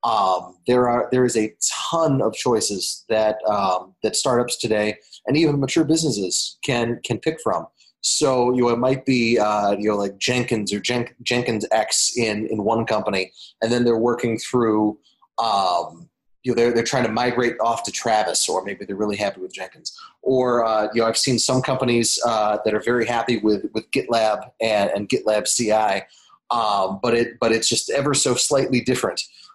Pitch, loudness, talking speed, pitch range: 115 Hz, -20 LUFS, 190 wpm, 110-125 Hz